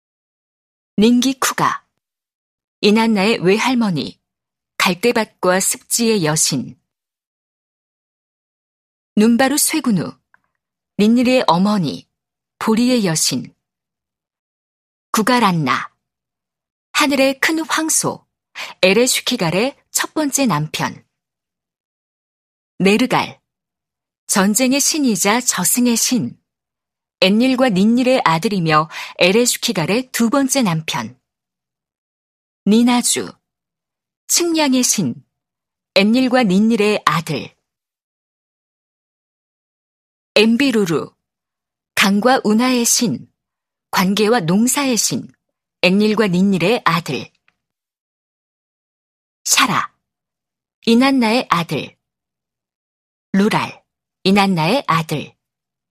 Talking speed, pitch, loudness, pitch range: 160 characters per minute, 220 Hz, -16 LUFS, 185-250 Hz